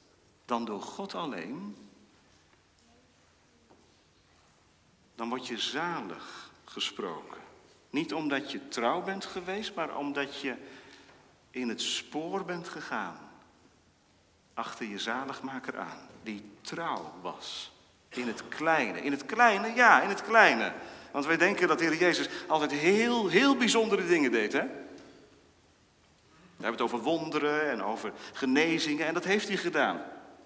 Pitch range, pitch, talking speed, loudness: 130-195 Hz, 160 Hz, 130 wpm, -29 LUFS